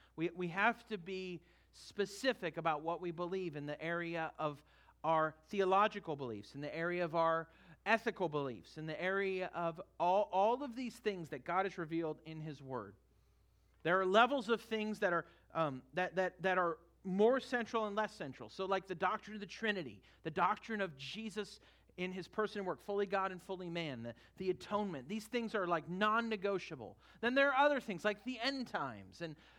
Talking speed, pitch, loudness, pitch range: 195 wpm, 185 Hz, -38 LUFS, 160-210 Hz